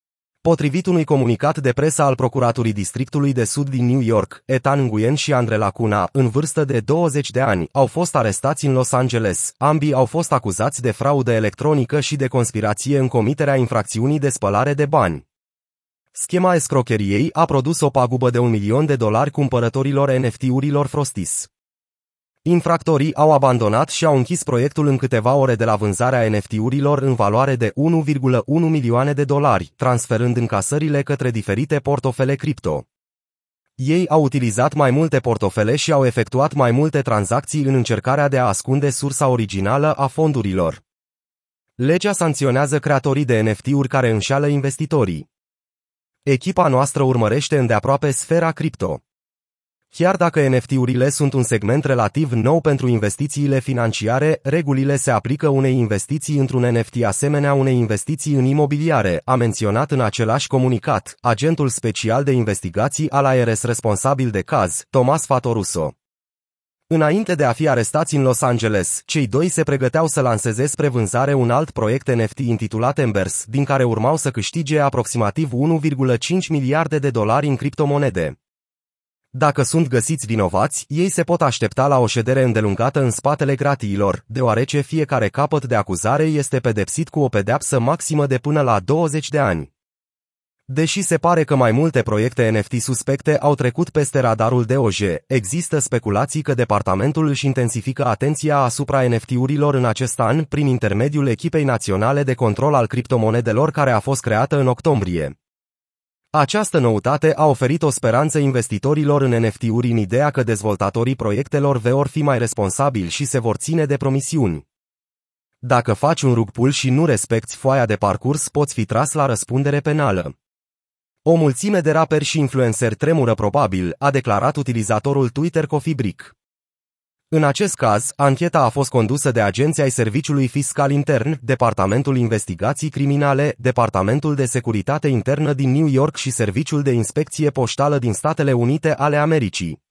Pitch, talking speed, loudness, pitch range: 135 Hz, 150 wpm, -18 LUFS, 115-145 Hz